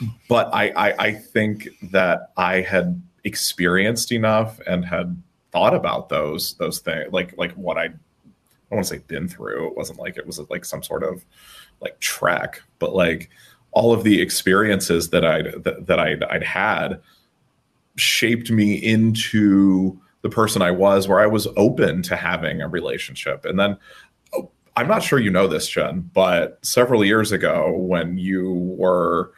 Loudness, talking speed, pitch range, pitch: -20 LUFS, 170 wpm, 95-115 Hz, 105 Hz